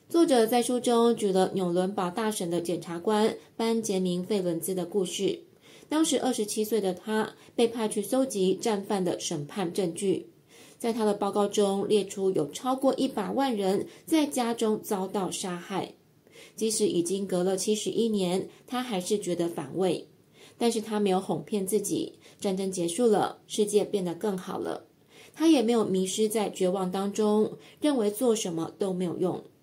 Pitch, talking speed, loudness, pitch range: 205 Hz, 255 characters per minute, -28 LUFS, 185-225 Hz